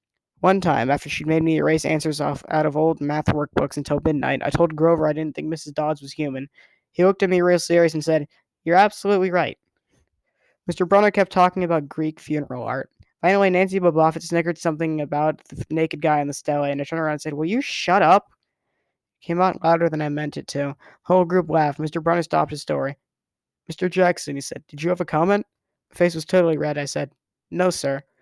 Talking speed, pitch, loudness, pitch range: 215 wpm, 160 Hz, -21 LUFS, 150-175 Hz